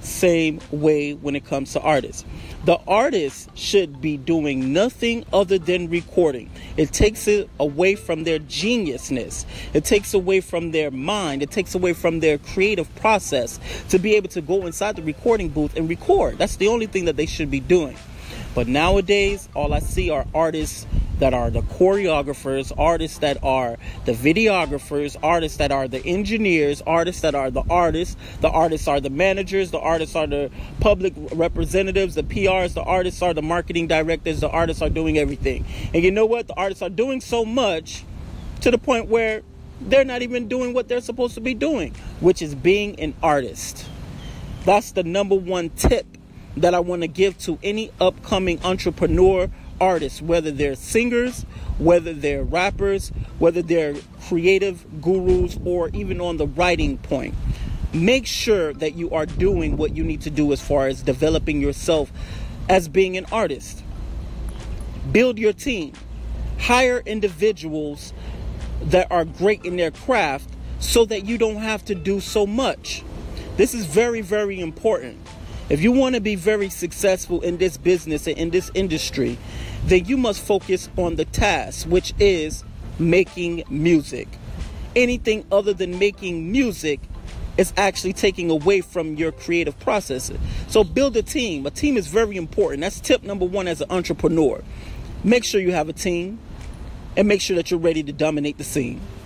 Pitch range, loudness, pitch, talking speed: 155-200 Hz, -21 LUFS, 175 Hz, 170 wpm